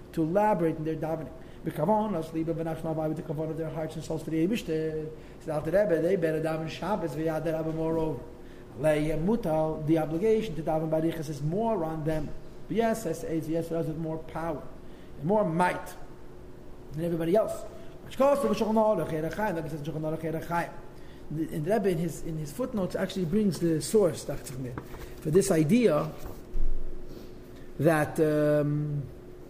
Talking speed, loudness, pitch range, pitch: 150 wpm, -29 LUFS, 155-170 Hz, 160 Hz